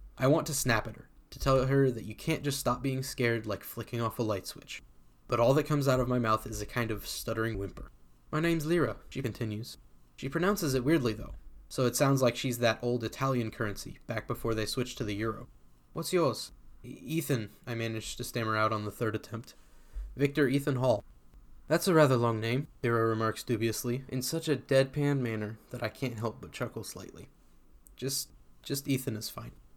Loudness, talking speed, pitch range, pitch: -31 LUFS, 205 wpm, 110-135 Hz, 120 Hz